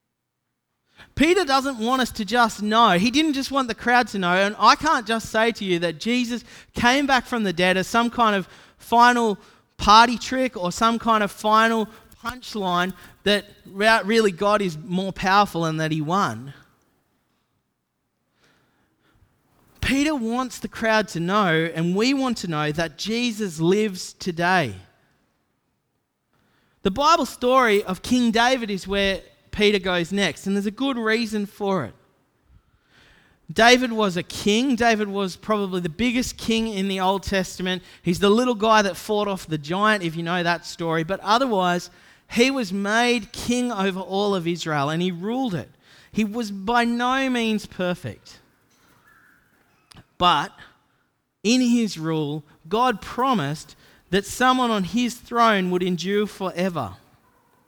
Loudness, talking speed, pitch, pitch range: -21 LUFS, 155 wpm, 210 Hz, 185-235 Hz